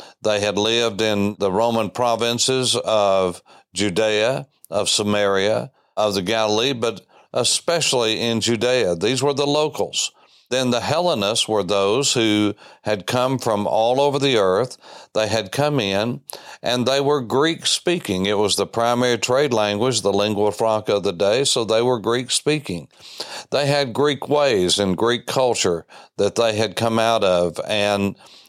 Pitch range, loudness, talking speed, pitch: 105-125 Hz, -19 LUFS, 160 wpm, 115 Hz